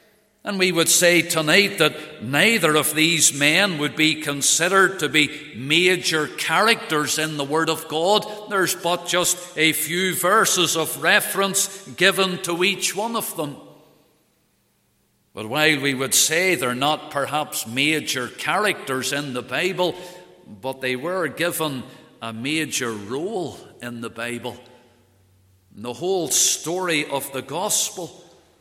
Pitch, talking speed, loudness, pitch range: 155 Hz, 140 wpm, -20 LUFS, 140-180 Hz